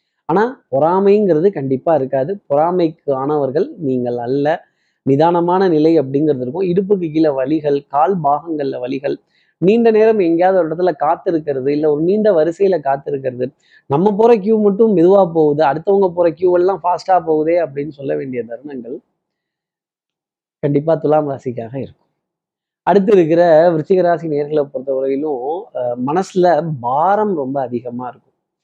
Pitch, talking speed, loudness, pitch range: 160 Hz, 125 wpm, -15 LUFS, 140-185 Hz